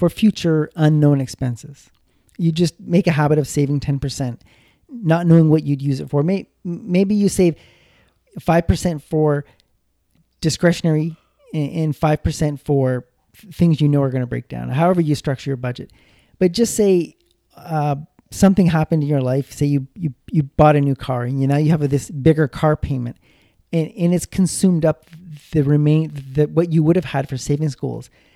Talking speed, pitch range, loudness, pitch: 175 wpm, 140-165 Hz, -18 LUFS, 150 Hz